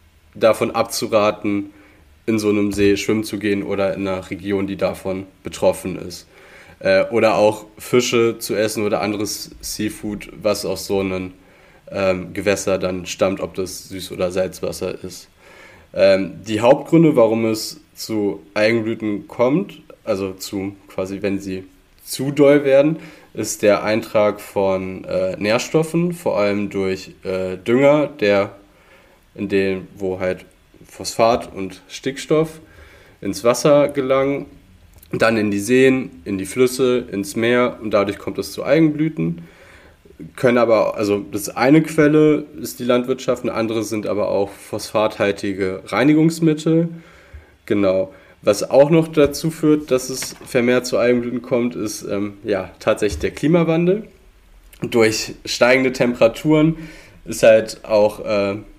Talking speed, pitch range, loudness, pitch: 130 wpm, 95-130 Hz, -18 LUFS, 105 Hz